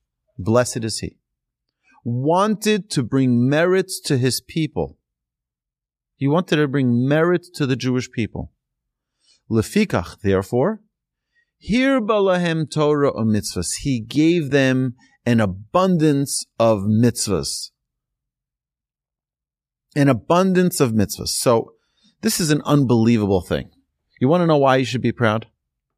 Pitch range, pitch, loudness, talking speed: 110-165 Hz, 130 Hz, -19 LUFS, 115 wpm